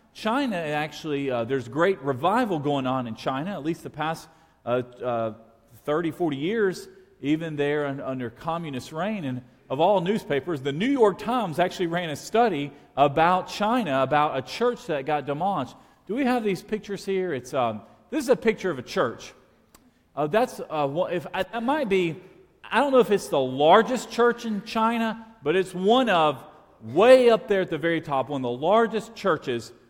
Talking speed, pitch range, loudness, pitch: 185 wpm, 140-215 Hz, -25 LUFS, 175 Hz